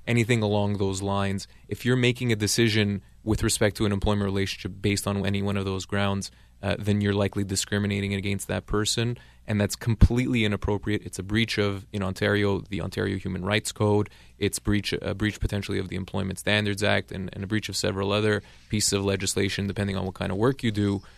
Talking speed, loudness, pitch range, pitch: 205 wpm, -26 LUFS, 100-105 Hz, 100 Hz